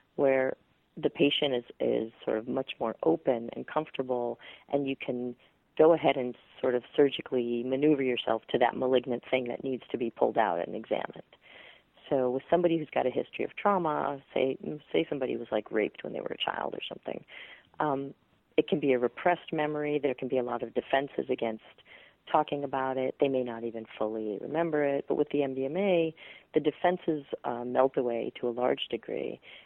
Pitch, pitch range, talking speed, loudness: 130 Hz, 125-150 Hz, 190 wpm, -30 LUFS